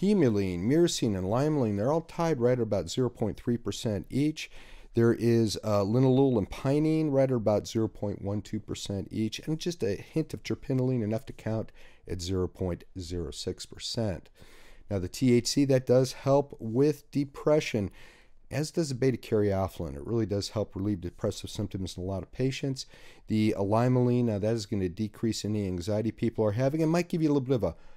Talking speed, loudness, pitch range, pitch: 175 wpm, -29 LUFS, 100-135 Hz, 115 Hz